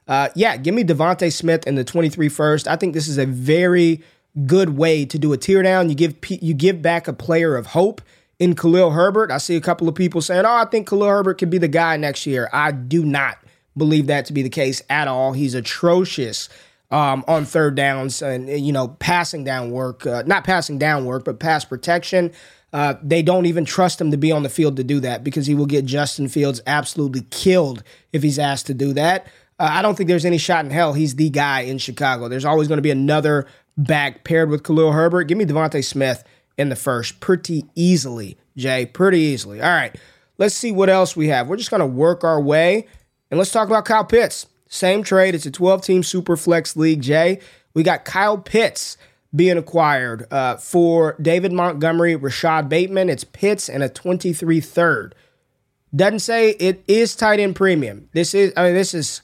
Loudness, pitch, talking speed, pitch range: -18 LUFS, 160 Hz, 210 wpm, 140-180 Hz